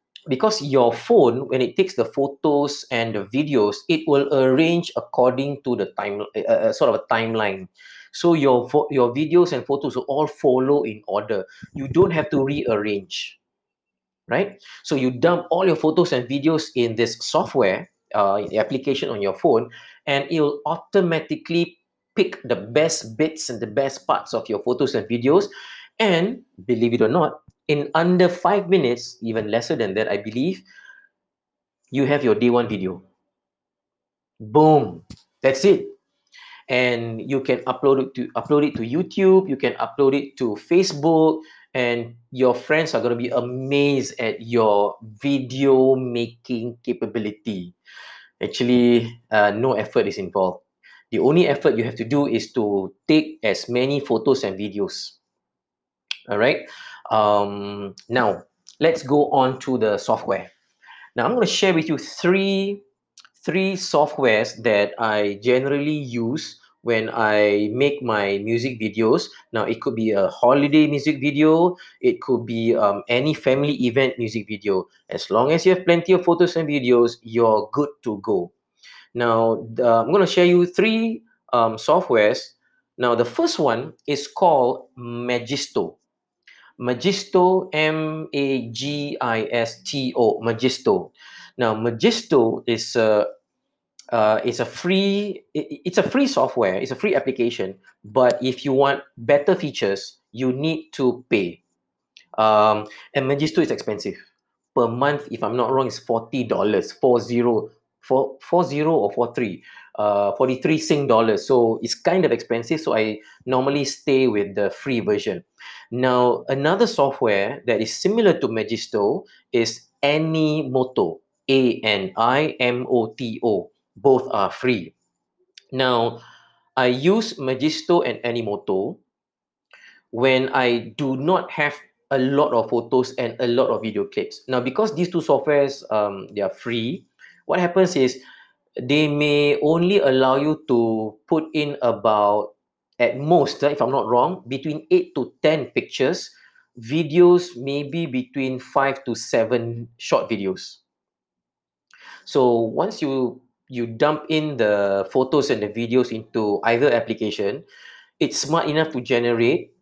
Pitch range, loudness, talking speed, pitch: 115-155 Hz, -21 LUFS, 145 wpm, 130 Hz